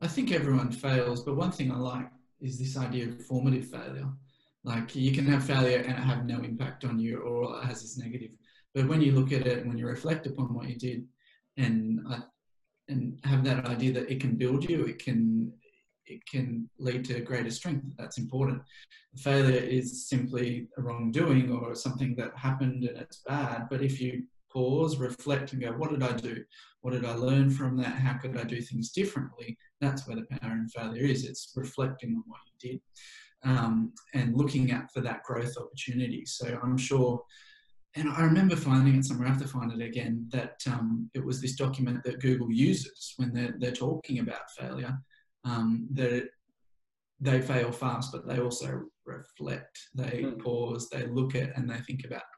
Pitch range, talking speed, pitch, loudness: 120-135 Hz, 195 wpm, 125 Hz, -31 LUFS